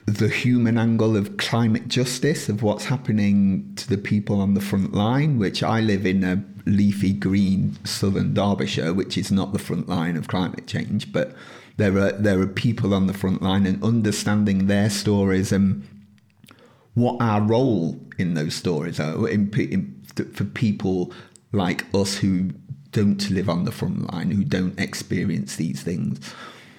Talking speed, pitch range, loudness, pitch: 165 wpm, 95-110 Hz, -22 LUFS, 100 Hz